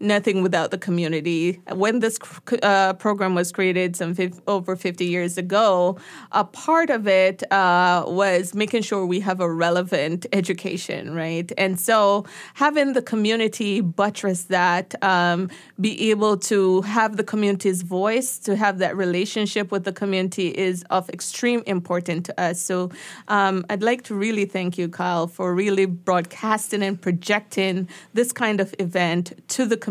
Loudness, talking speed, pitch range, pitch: -22 LUFS, 160 wpm, 180-210 Hz, 190 Hz